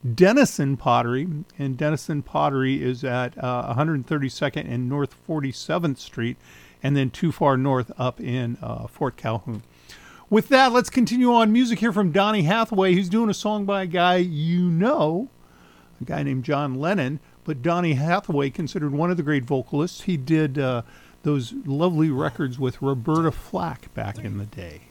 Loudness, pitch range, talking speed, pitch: -23 LUFS, 125-175 Hz, 165 wpm, 145 Hz